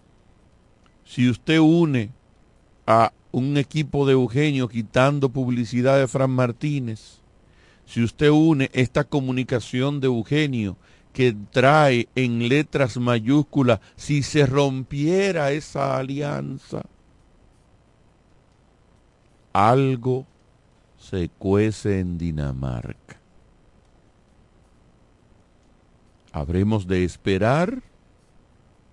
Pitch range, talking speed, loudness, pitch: 110-140 Hz, 80 wpm, -21 LUFS, 125 Hz